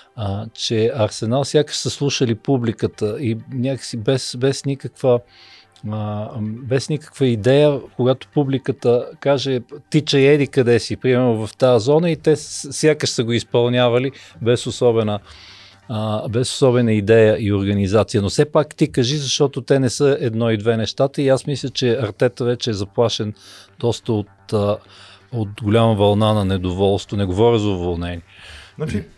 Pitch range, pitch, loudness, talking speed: 105-135 Hz, 120 Hz, -19 LUFS, 145 wpm